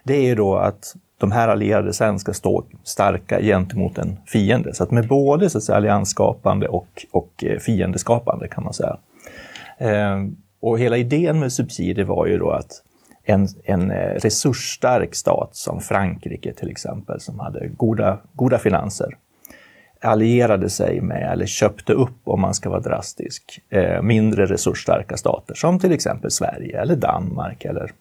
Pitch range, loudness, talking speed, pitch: 100-130 Hz, -20 LUFS, 150 wpm, 110 Hz